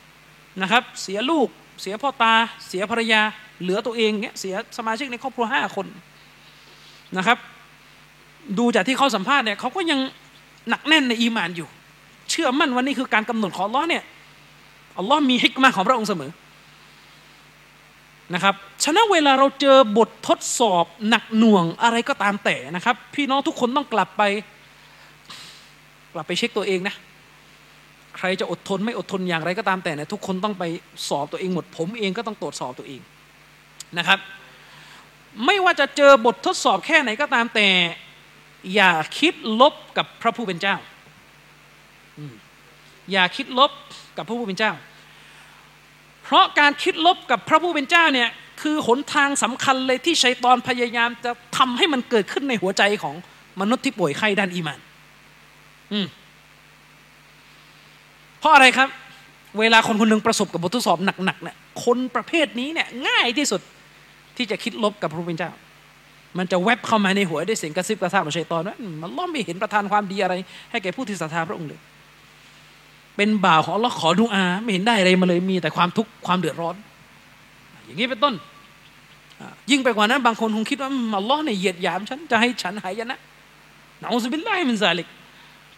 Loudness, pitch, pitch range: -20 LUFS, 220 Hz, 185-255 Hz